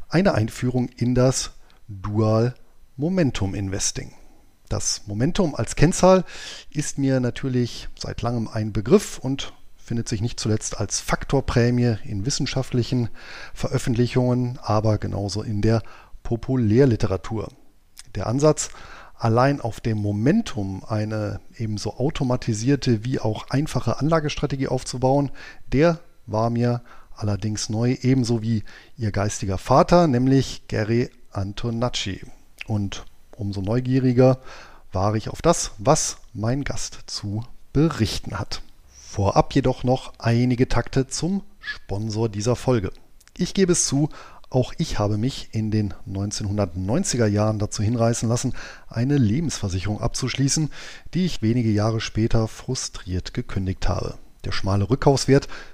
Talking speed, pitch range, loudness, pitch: 120 wpm, 105-130 Hz, -23 LUFS, 120 Hz